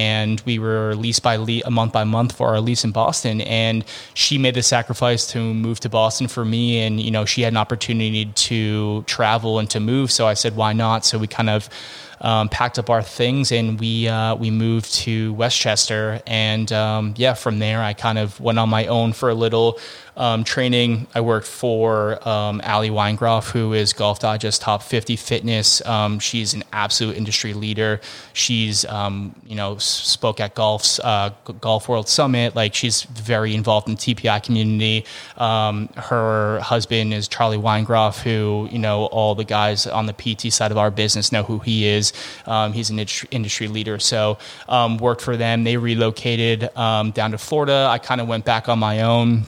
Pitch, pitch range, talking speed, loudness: 110 Hz, 110-115 Hz, 195 wpm, -19 LUFS